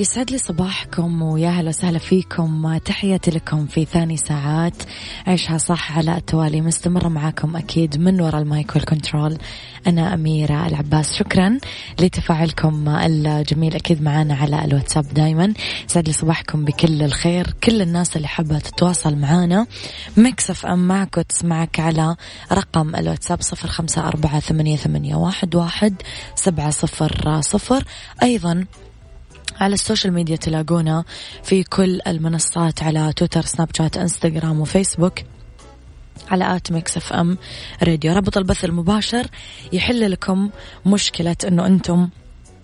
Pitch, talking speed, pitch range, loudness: 165 Hz, 125 wpm, 155-180 Hz, -19 LUFS